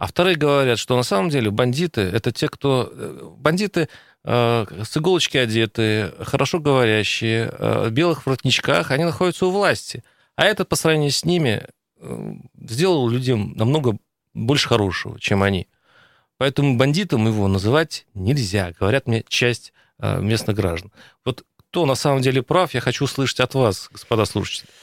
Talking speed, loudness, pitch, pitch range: 155 wpm, -20 LUFS, 130 Hz, 115-150 Hz